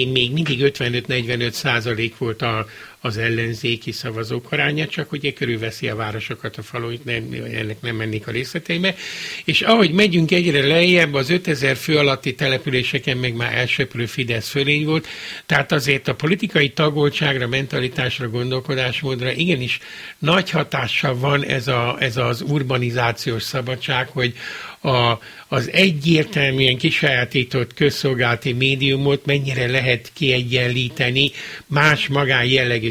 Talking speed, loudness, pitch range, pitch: 130 wpm, -19 LUFS, 120-145 Hz, 130 Hz